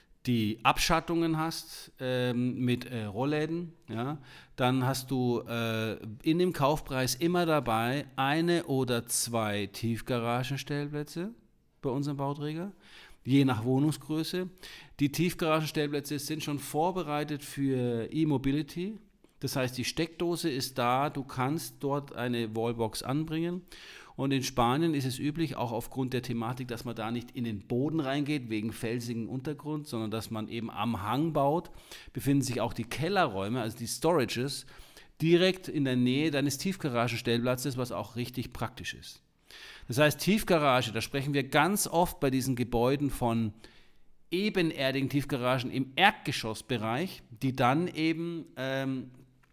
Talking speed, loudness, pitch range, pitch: 135 wpm, -31 LUFS, 120-155 Hz, 135 Hz